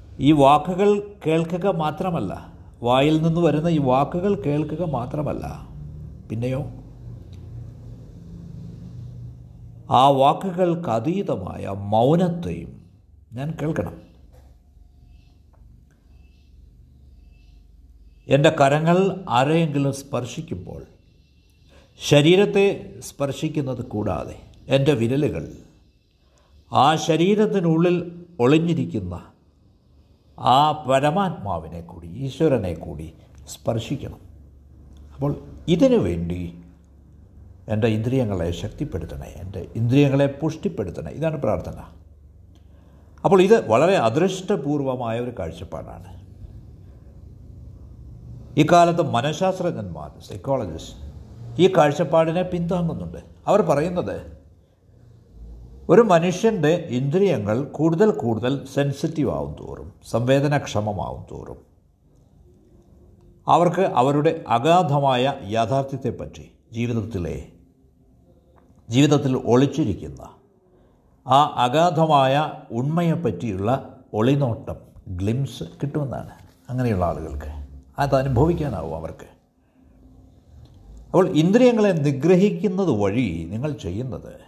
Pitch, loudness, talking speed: 120 Hz, -21 LUFS, 65 wpm